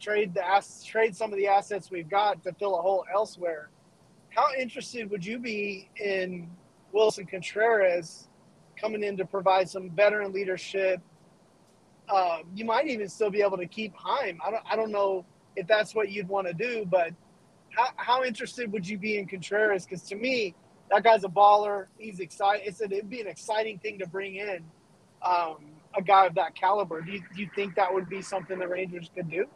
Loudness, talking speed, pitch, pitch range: -28 LUFS, 195 wpm, 195 Hz, 185-210 Hz